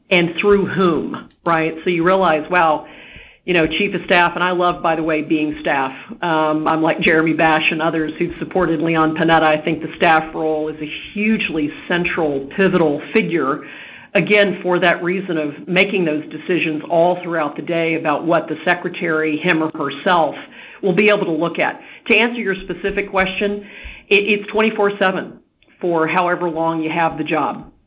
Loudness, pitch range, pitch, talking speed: -17 LUFS, 160-185 Hz, 170 Hz, 175 wpm